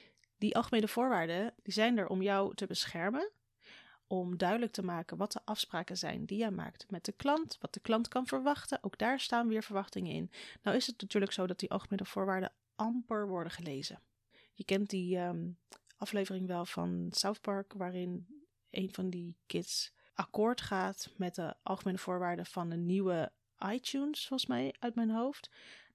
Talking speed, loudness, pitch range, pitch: 175 wpm, -36 LUFS, 180-225 Hz, 195 Hz